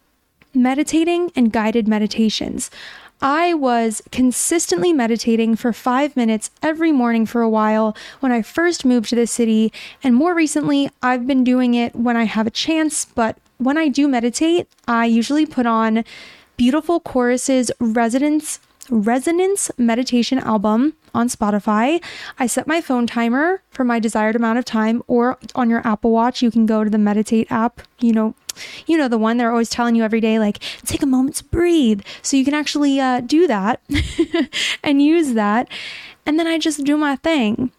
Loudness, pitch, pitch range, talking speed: -18 LUFS, 250 Hz, 230-295 Hz, 175 wpm